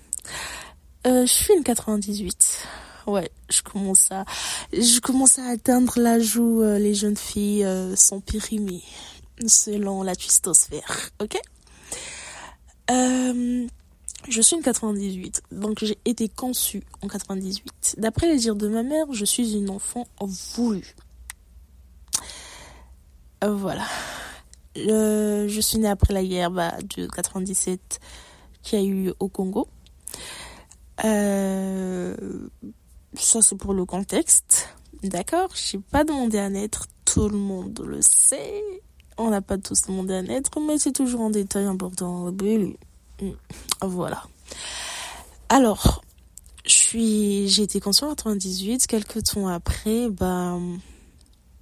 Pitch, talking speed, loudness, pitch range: 205 Hz, 125 wpm, -21 LUFS, 190-230 Hz